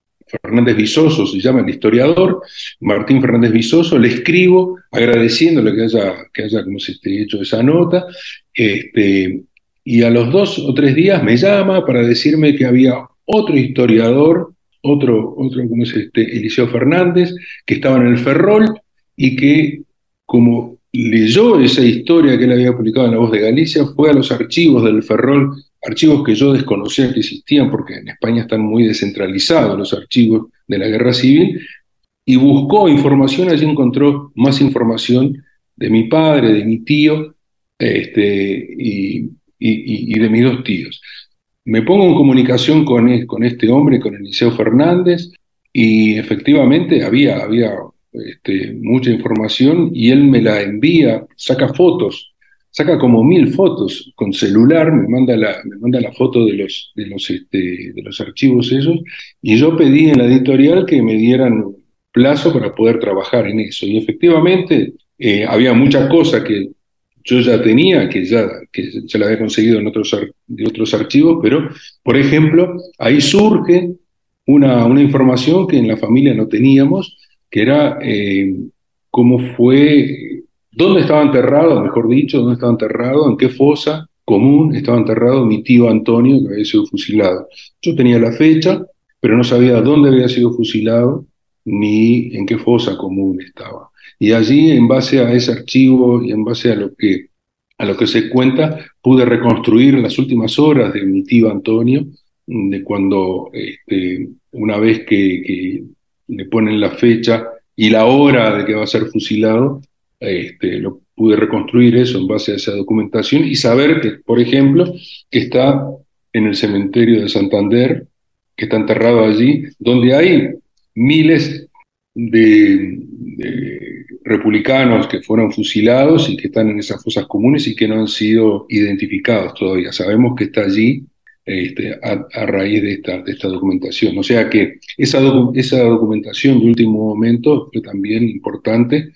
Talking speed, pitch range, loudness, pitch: 160 wpm, 110-145 Hz, -12 LUFS, 125 Hz